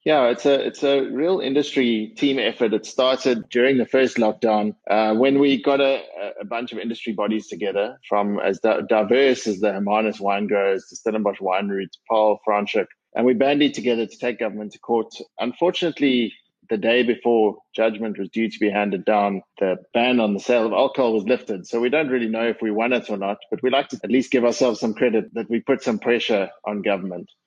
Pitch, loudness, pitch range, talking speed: 115 Hz, -21 LUFS, 105-130 Hz, 215 wpm